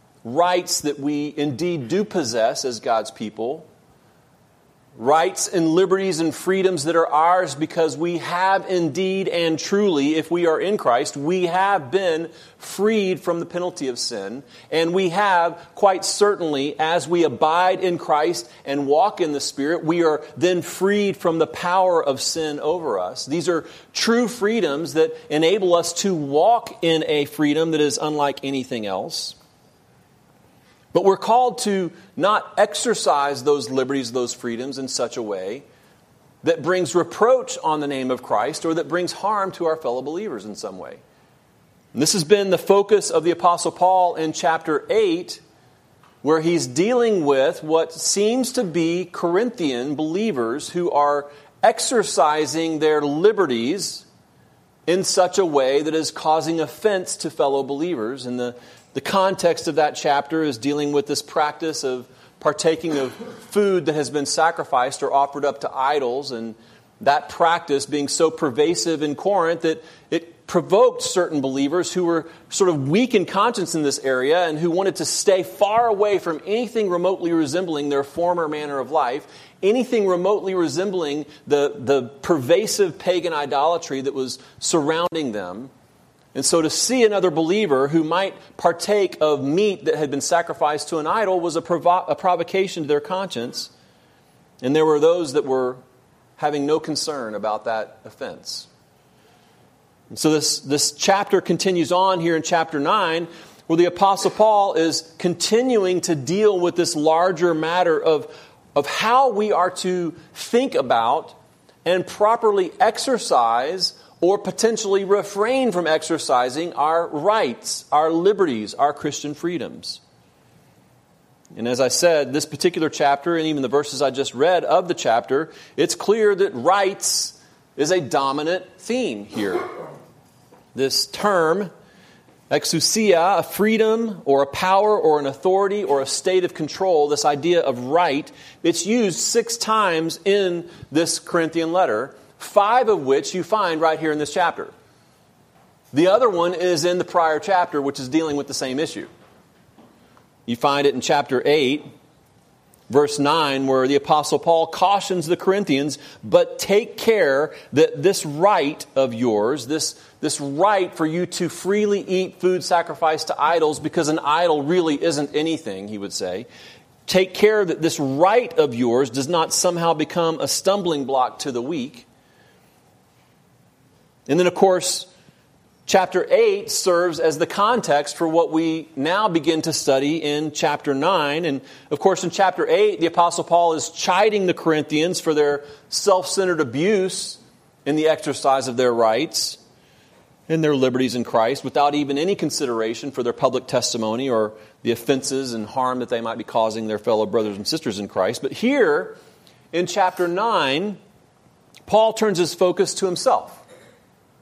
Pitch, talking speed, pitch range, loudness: 165 Hz, 160 wpm, 145-190 Hz, -20 LUFS